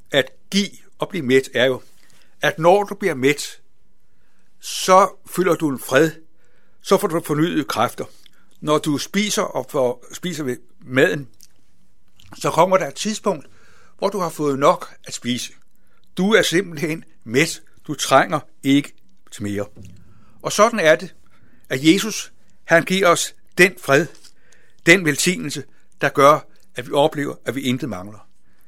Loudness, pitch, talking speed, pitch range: -19 LUFS, 155 Hz, 150 wpm, 130-185 Hz